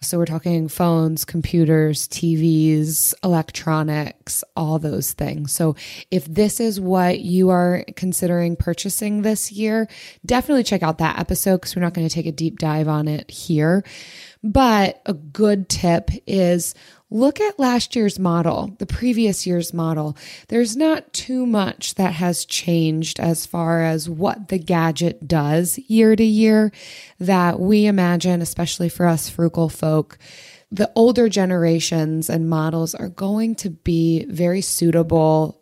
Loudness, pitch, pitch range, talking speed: -19 LUFS, 175 Hz, 160-200 Hz, 150 wpm